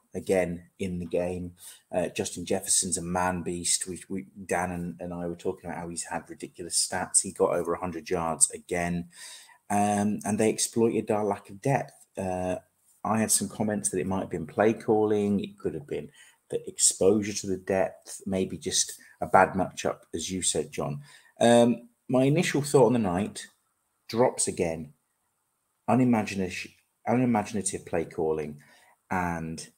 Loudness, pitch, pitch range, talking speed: -27 LUFS, 95 Hz, 85-105 Hz, 165 wpm